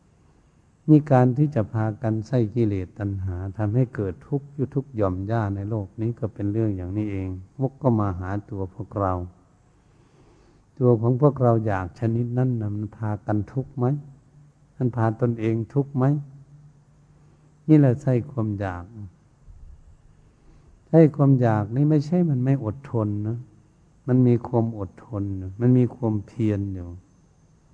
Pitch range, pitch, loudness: 105-135 Hz, 115 Hz, -24 LUFS